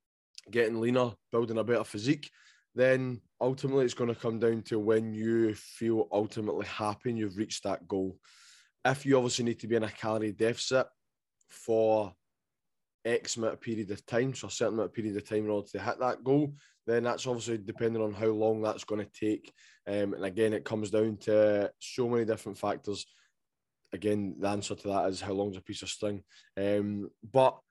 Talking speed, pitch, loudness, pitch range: 195 wpm, 110 Hz, -31 LUFS, 105-115 Hz